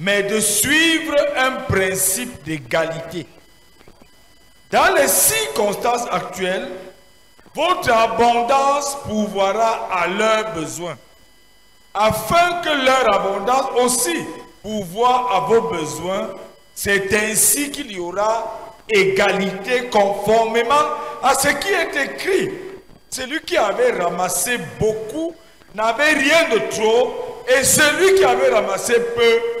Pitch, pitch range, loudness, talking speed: 225 Hz, 200-295 Hz, -17 LUFS, 105 wpm